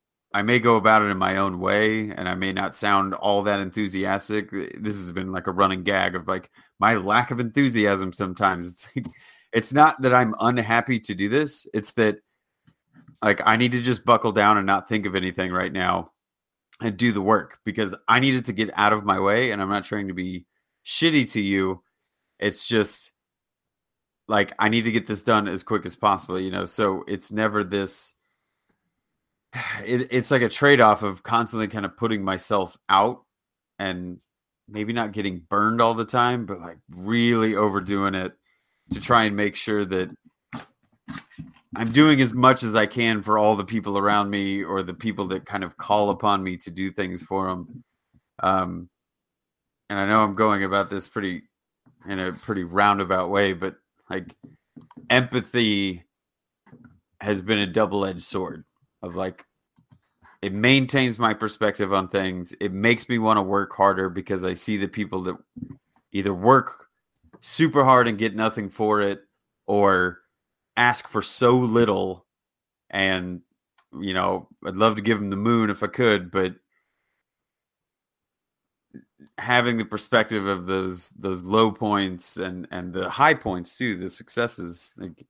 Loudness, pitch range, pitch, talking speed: -22 LUFS, 95-115 Hz, 105 Hz, 175 wpm